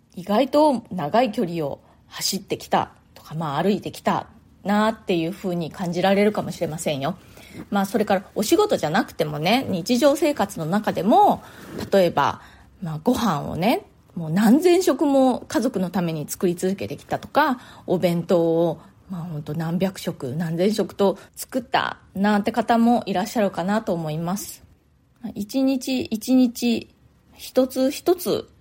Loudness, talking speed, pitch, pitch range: -22 LUFS, 290 characters per minute, 200 Hz, 180-245 Hz